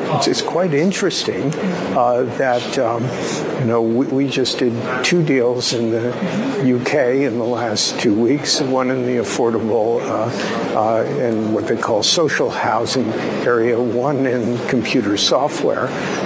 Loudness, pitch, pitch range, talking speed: -17 LUFS, 125 Hz, 120-130 Hz, 145 wpm